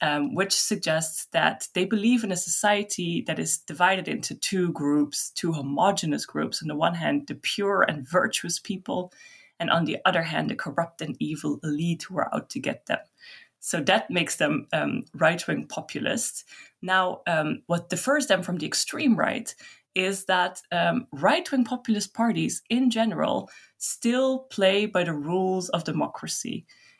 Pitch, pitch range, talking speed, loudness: 185 Hz, 170-225 Hz, 170 wpm, -25 LUFS